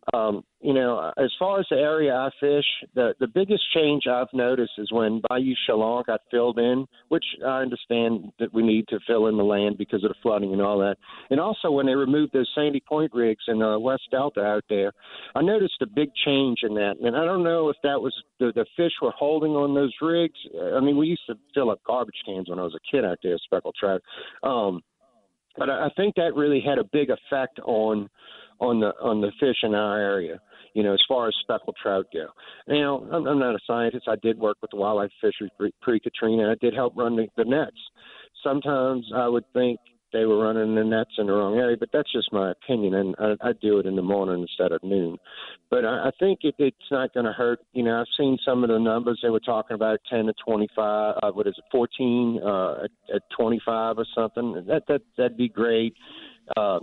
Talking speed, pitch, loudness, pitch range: 230 wpm, 120 Hz, -24 LUFS, 110-140 Hz